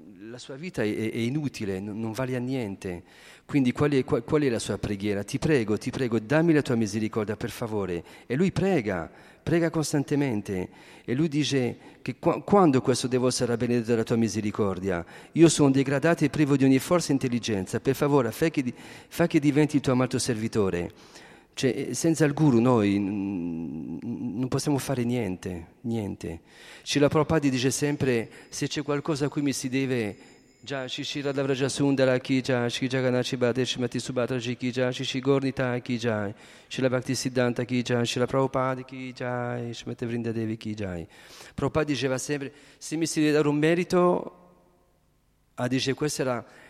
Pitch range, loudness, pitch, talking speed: 115-145 Hz, -26 LUFS, 130 Hz, 175 wpm